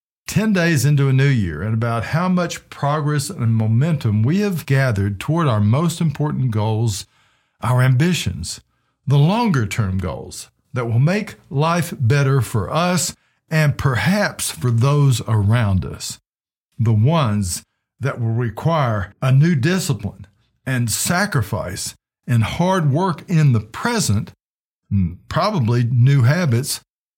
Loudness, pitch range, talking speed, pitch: -19 LUFS, 110-155 Hz, 130 wpm, 130 Hz